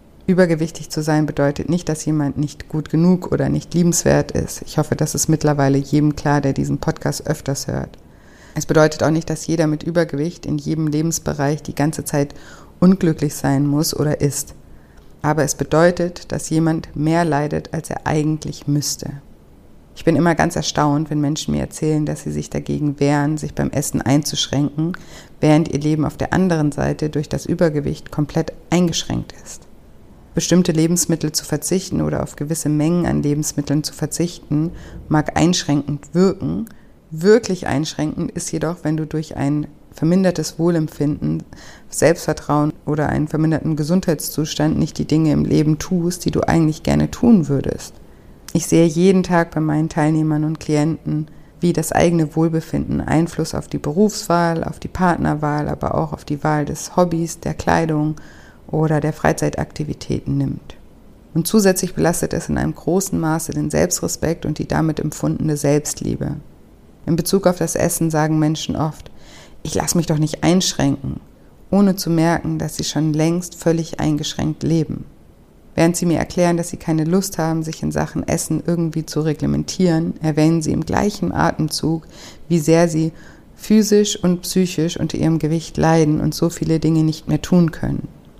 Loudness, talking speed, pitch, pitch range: -19 LUFS, 165 wpm, 155 Hz, 145-165 Hz